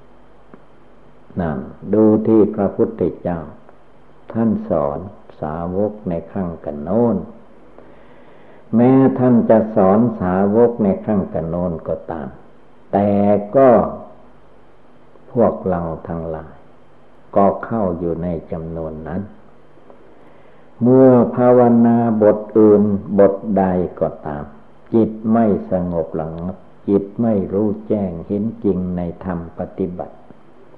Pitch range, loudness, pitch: 85-110 Hz, -17 LUFS, 100 Hz